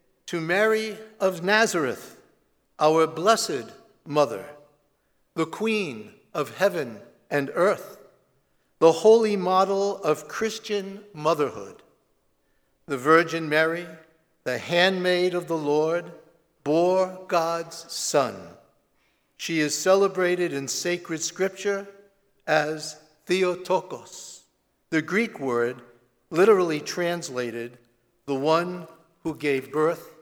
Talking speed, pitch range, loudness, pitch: 95 wpm, 150-190 Hz, -24 LUFS, 165 Hz